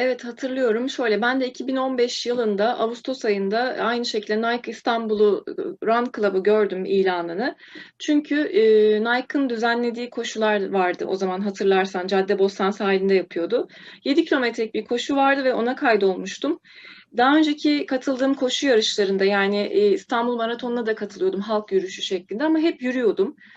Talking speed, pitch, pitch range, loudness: 140 wpm, 235 Hz, 205-265 Hz, -22 LUFS